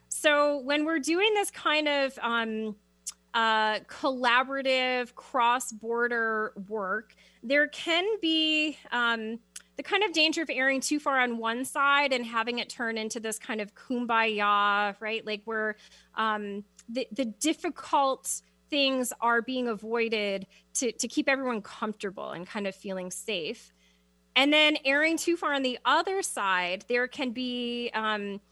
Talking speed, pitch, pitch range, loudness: 150 wpm, 240 Hz, 215-285 Hz, -28 LUFS